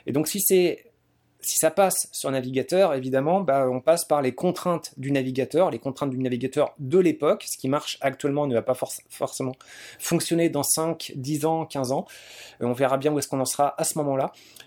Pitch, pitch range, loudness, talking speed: 145 Hz, 130-160 Hz, -24 LUFS, 215 wpm